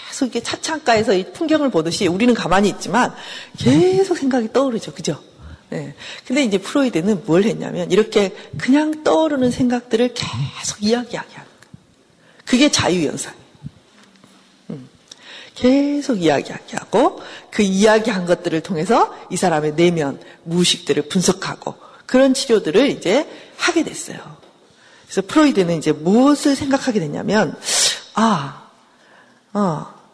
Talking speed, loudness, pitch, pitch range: 305 characters per minute, -18 LUFS, 230 Hz, 180-270 Hz